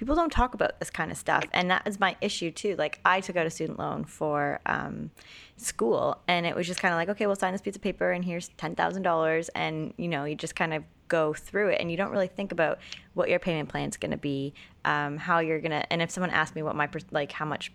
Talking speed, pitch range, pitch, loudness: 270 wpm, 155-185 Hz, 170 Hz, -29 LUFS